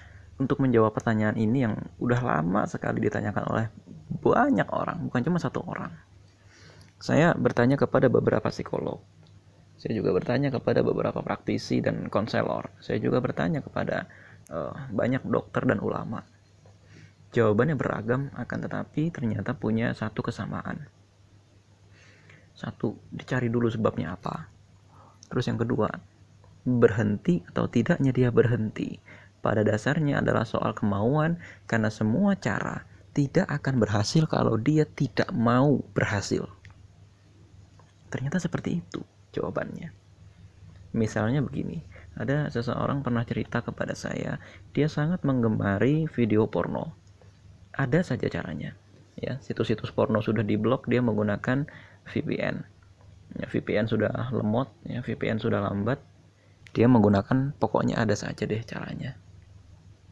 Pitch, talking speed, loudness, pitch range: 110 Hz, 120 wpm, -27 LUFS, 100-125 Hz